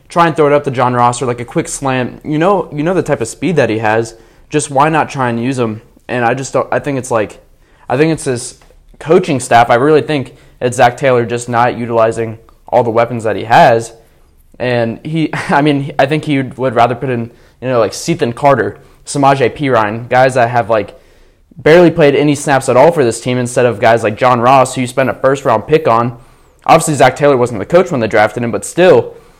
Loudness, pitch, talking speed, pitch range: -12 LUFS, 125 Hz, 240 wpm, 115-145 Hz